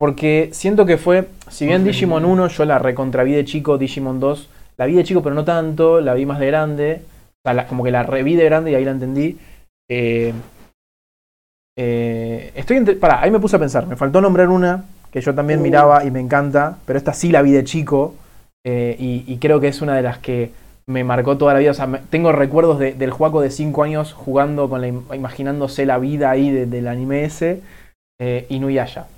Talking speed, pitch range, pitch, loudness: 220 wpm, 130-160 Hz, 140 Hz, -17 LUFS